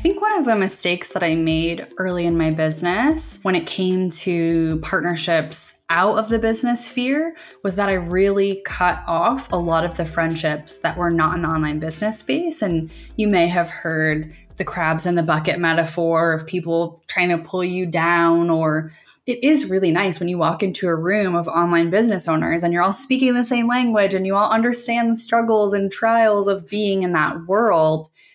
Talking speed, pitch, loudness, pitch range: 200 wpm, 180 Hz, -19 LUFS, 165-210 Hz